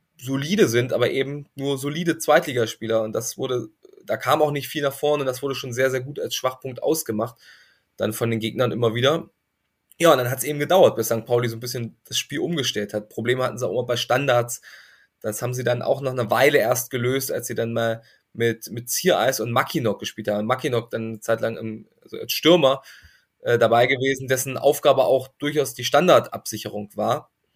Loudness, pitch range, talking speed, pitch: -22 LUFS, 115-140 Hz, 205 wpm, 125 Hz